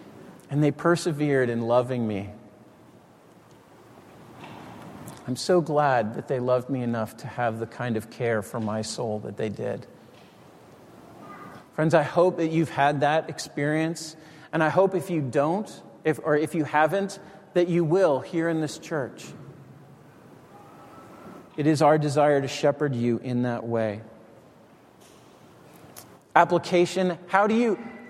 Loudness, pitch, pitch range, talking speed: -25 LUFS, 150 Hz, 125-165 Hz, 140 wpm